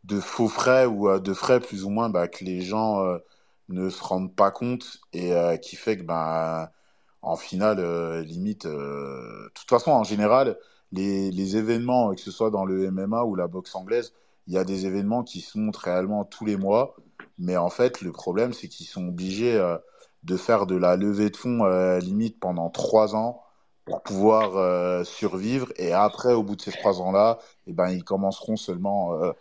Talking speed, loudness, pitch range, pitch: 210 wpm, -25 LUFS, 90-110 Hz, 100 Hz